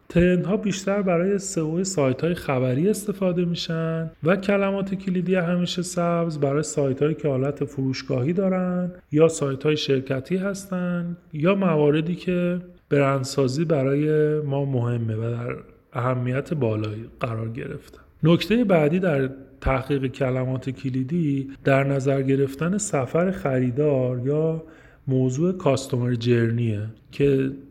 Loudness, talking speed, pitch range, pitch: -23 LUFS, 120 wpm, 135-175 Hz, 150 Hz